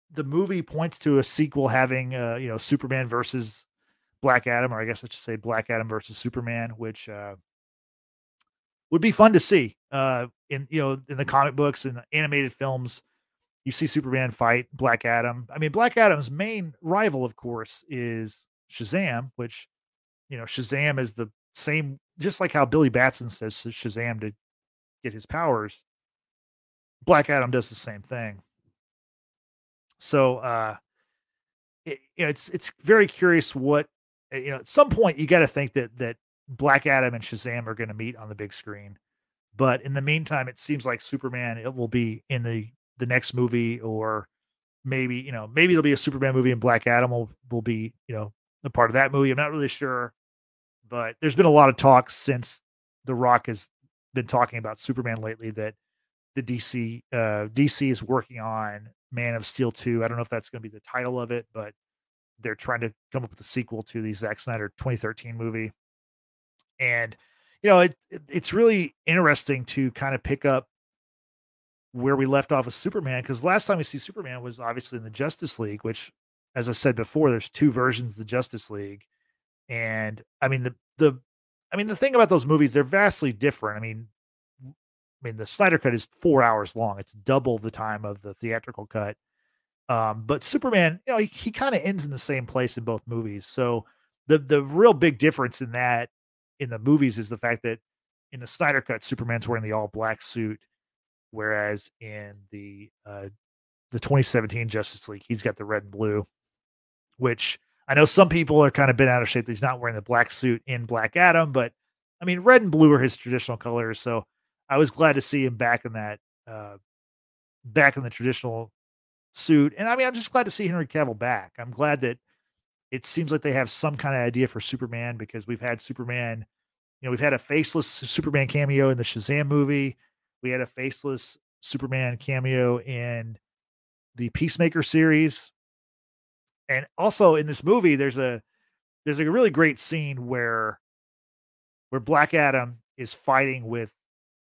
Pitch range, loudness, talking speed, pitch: 115-140 Hz, -24 LUFS, 195 wpm, 125 Hz